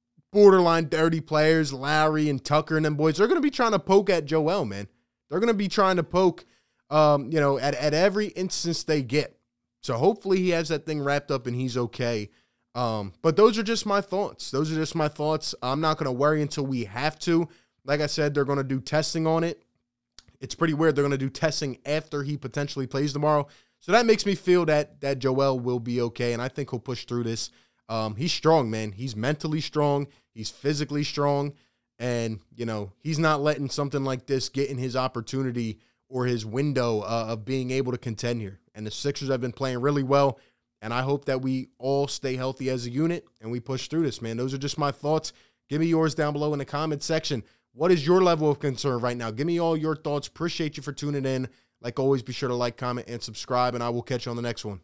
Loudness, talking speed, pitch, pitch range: -26 LUFS, 235 wpm, 140 Hz, 125-155 Hz